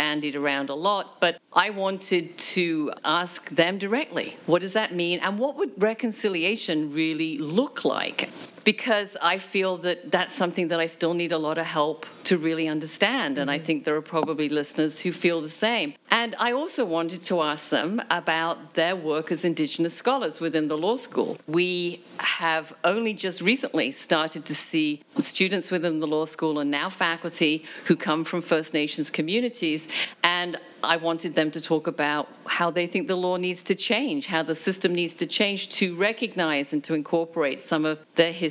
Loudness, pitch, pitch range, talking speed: -25 LUFS, 175 Hz, 160-195 Hz, 185 wpm